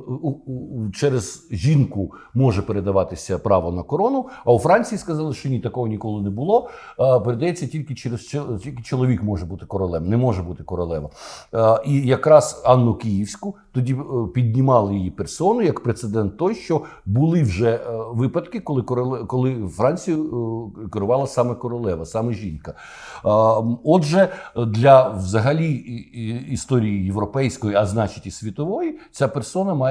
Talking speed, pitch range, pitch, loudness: 130 wpm, 105-140 Hz, 120 Hz, -21 LUFS